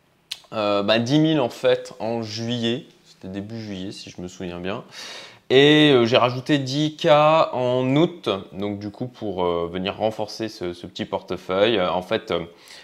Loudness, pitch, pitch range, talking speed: -21 LUFS, 110 Hz, 95-130 Hz, 180 wpm